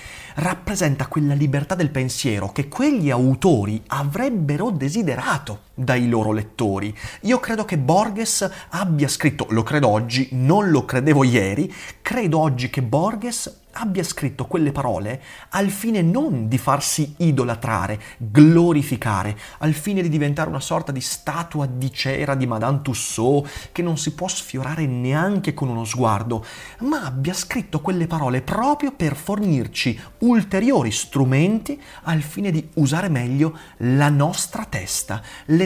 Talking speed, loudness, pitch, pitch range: 140 wpm, -21 LUFS, 145 Hz, 130-175 Hz